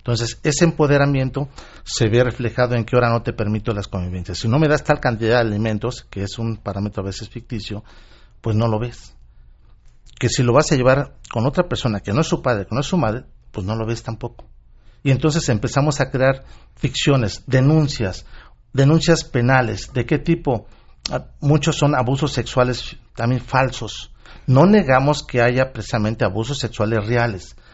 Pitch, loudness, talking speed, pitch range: 120 Hz, -19 LUFS, 180 wpm, 110-135 Hz